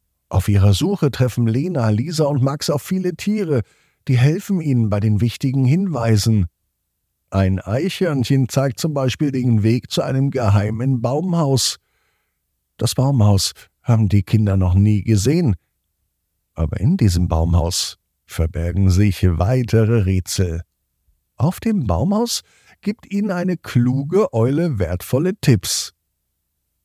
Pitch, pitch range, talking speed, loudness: 115 Hz, 90-140 Hz, 125 wpm, -18 LUFS